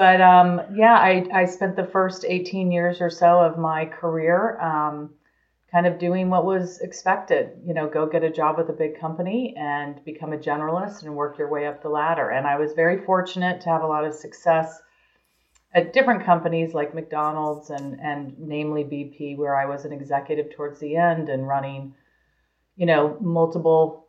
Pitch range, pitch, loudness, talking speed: 150-180 Hz, 160 Hz, -22 LUFS, 190 wpm